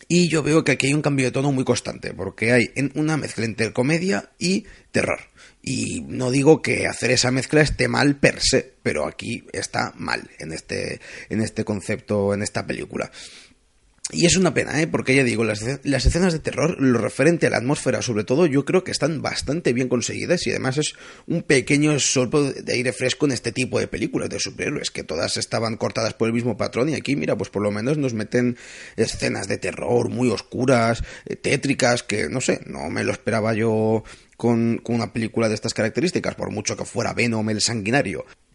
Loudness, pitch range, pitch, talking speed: -22 LUFS, 115-145 Hz, 125 Hz, 205 wpm